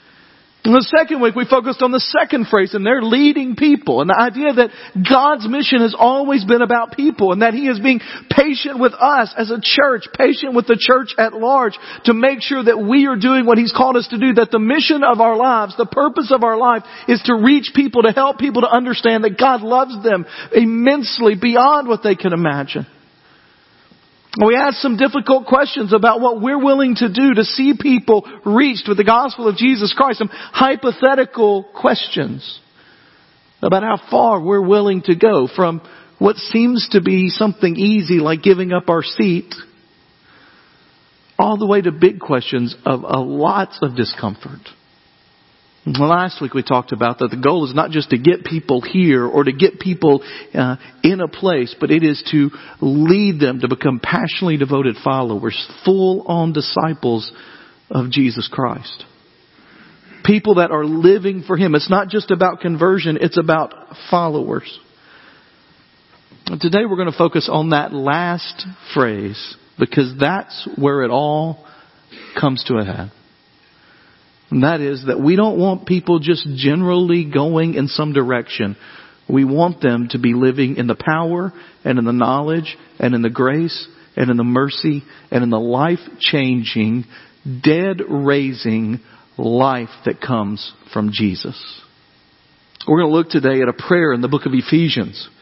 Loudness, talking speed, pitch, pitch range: -15 LUFS, 170 wpm, 185 Hz, 140-235 Hz